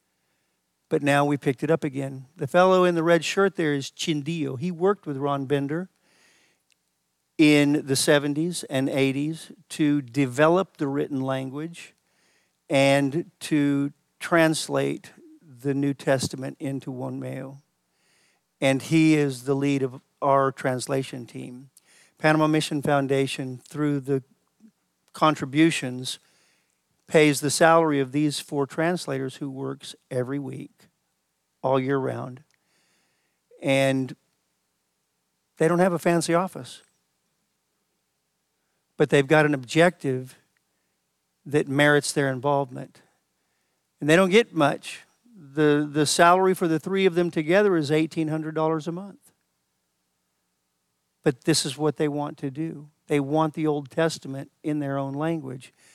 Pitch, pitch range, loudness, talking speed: 145 Hz, 135-160 Hz, -24 LUFS, 130 wpm